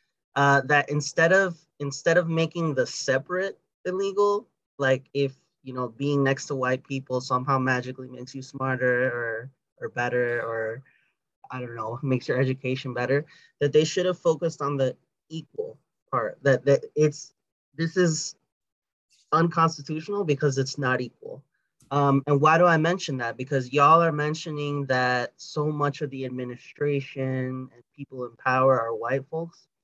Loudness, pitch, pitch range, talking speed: -25 LUFS, 140 Hz, 130-160 Hz, 155 wpm